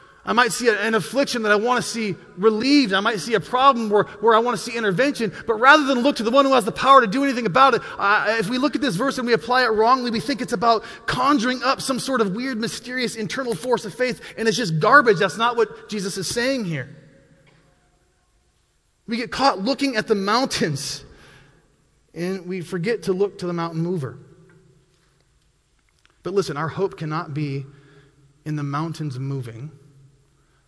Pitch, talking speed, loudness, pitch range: 220 Hz, 200 wpm, -20 LUFS, 165-245 Hz